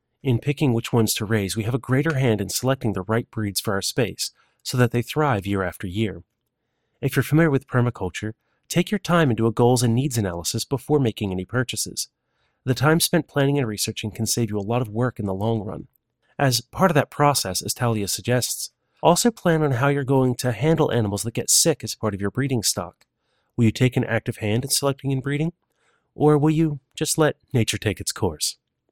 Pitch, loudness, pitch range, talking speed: 120 Hz, -22 LUFS, 110-140 Hz, 220 wpm